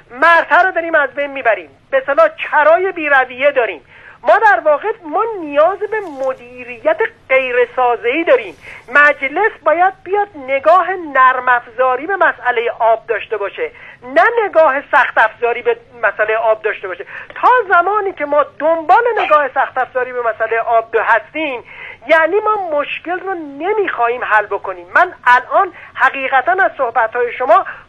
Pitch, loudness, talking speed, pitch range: 300 Hz, -14 LUFS, 145 wpm, 250-375 Hz